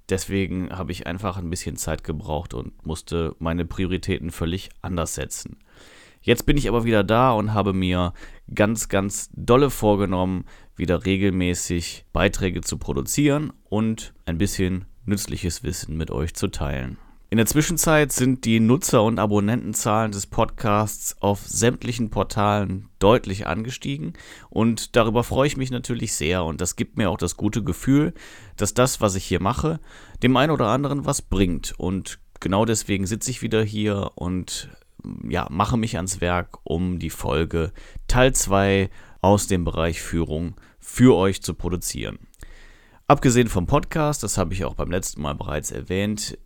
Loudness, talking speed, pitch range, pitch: -23 LUFS, 160 wpm, 90-115 Hz, 100 Hz